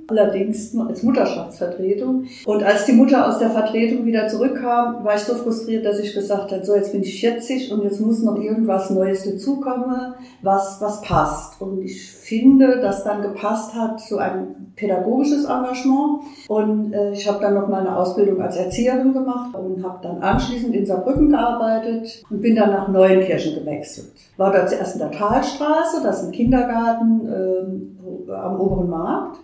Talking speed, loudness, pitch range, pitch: 175 wpm, -19 LUFS, 195-245 Hz, 215 Hz